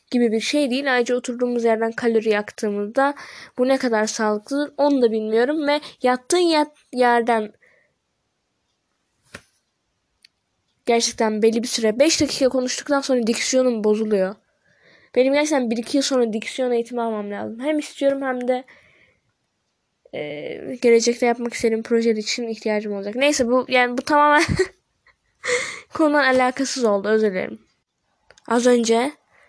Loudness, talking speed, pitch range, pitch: -20 LUFS, 130 wpm, 225-275 Hz, 245 Hz